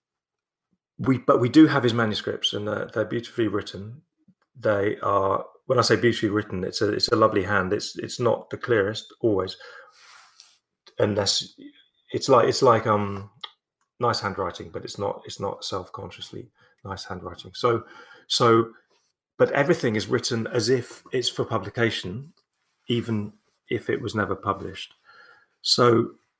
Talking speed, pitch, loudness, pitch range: 150 wpm, 115 Hz, -24 LUFS, 100-120 Hz